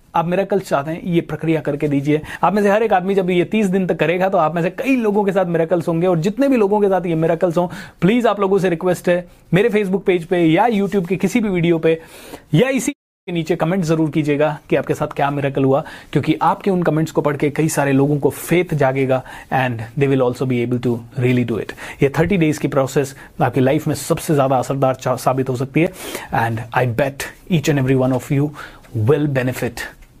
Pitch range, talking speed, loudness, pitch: 140-185 Hz, 235 wpm, -18 LUFS, 160 Hz